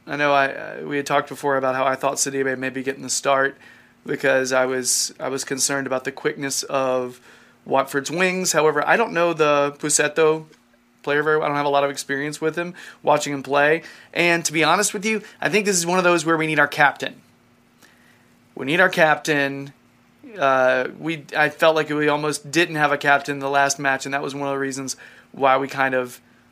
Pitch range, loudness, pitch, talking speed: 135-155 Hz, -20 LUFS, 140 Hz, 220 wpm